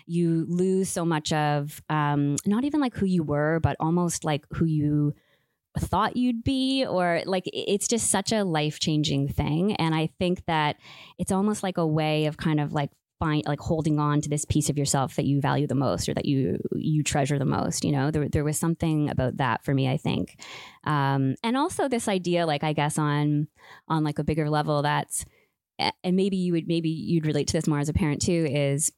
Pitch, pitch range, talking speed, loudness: 155 Hz, 145-175 Hz, 215 wpm, -26 LUFS